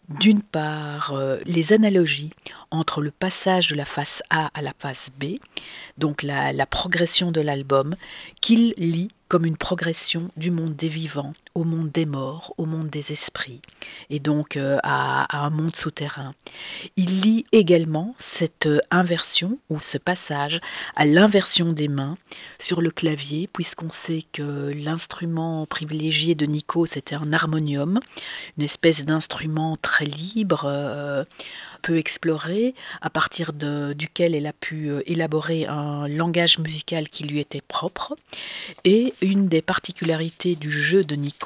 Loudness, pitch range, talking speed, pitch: -22 LUFS, 150-175 Hz, 150 wpm, 160 Hz